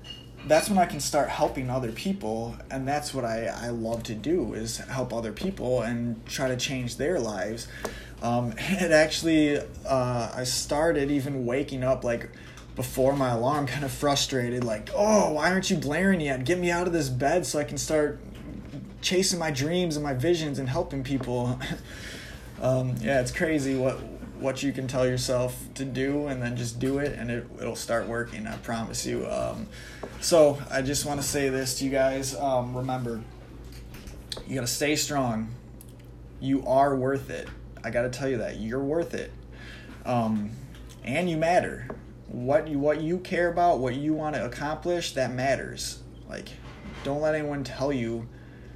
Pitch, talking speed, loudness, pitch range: 135 Hz, 180 wpm, -27 LUFS, 120-150 Hz